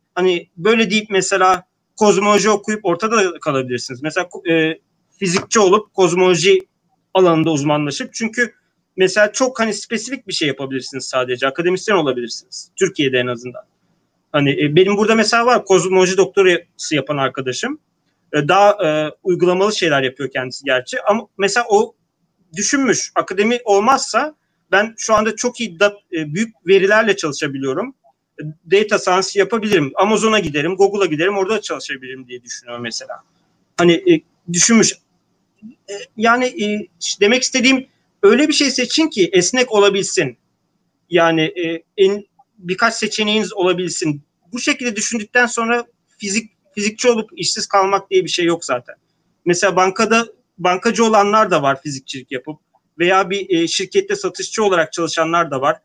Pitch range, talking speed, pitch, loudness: 165-215 Hz, 135 wpm, 190 Hz, -16 LUFS